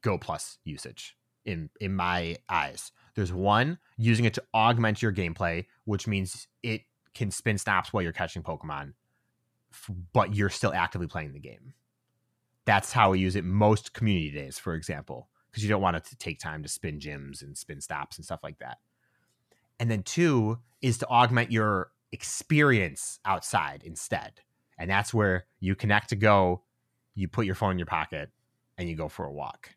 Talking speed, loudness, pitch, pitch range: 180 wpm, -28 LUFS, 105 Hz, 90-115 Hz